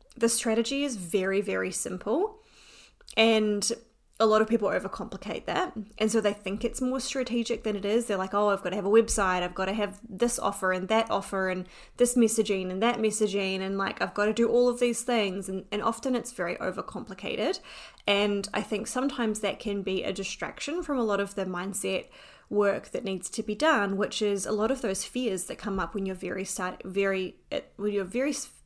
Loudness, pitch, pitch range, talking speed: -28 LUFS, 210 Hz, 195-230 Hz, 215 wpm